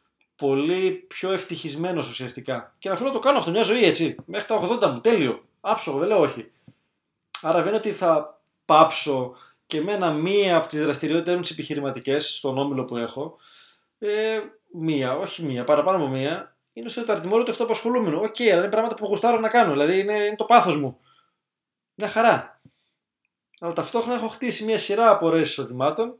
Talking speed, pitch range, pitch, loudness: 180 wpm, 150-225 Hz, 190 Hz, -23 LUFS